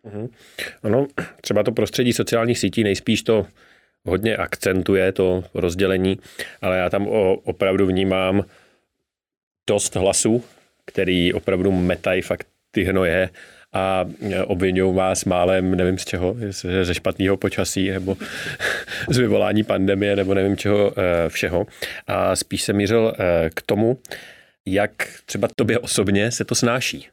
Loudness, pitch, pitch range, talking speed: -21 LUFS, 95 Hz, 95-105 Hz, 130 wpm